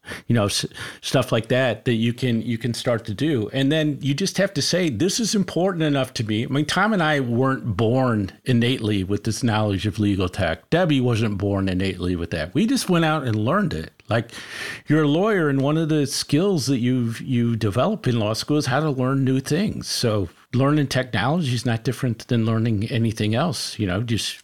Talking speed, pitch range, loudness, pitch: 220 wpm, 110-145 Hz, -22 LUFS, 125 Hz